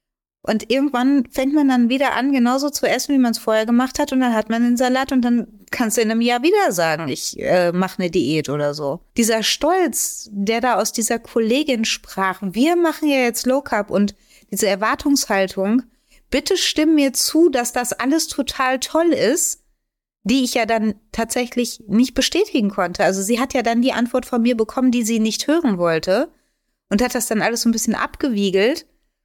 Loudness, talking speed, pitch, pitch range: -18 LUFS, 200 wpm, 240 Hz, 220-270 Hz